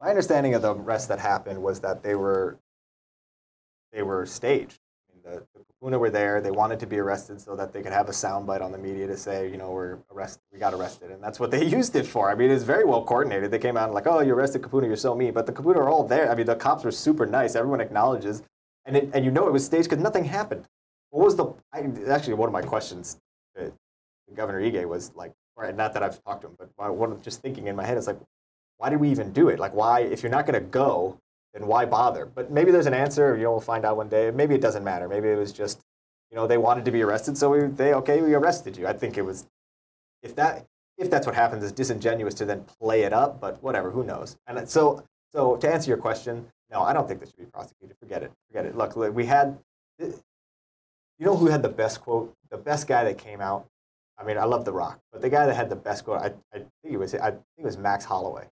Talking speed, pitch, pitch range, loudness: 260 wpm, 115 Hz, 100-135 Hz, -25 LUFS